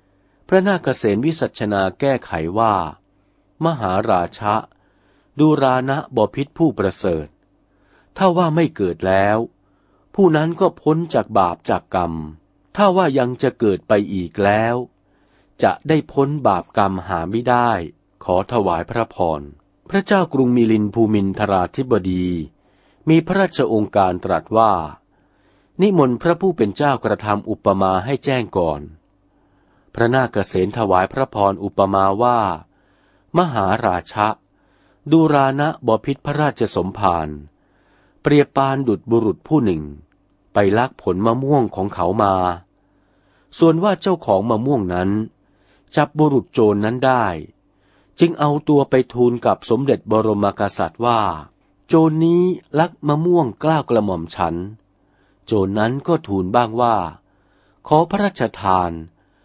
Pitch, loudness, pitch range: 110 Hz, -18 LUFS, 95-145 Hz